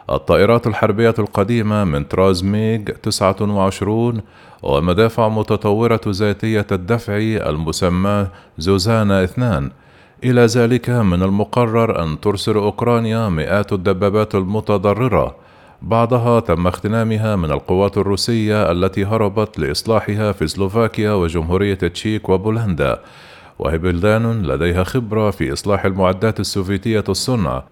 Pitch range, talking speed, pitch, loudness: 95-110 Hz, 100 wpm, 105 Hz, -17 LUFS